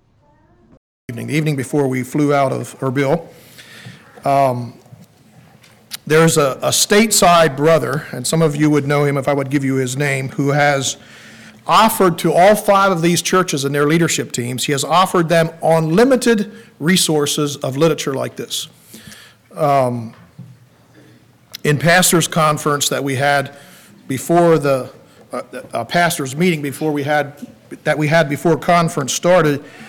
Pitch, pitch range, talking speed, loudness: 150 Hz, 140-170 Hz, 150 wpm, -15 LUFS